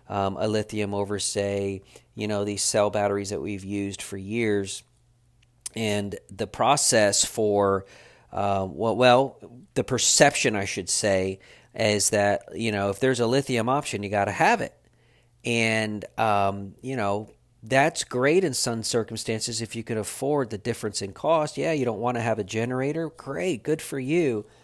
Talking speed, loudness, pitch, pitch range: 170 wpm, -25 LUFS, 110 Hz, 100-120 Hz